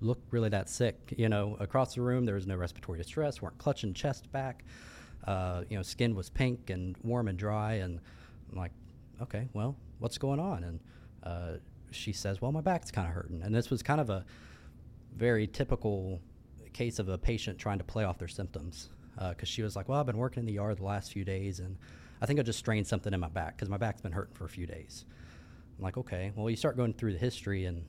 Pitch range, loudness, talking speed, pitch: 90-120 Hz, -35 LUFS, 235 wpm, 105 Hz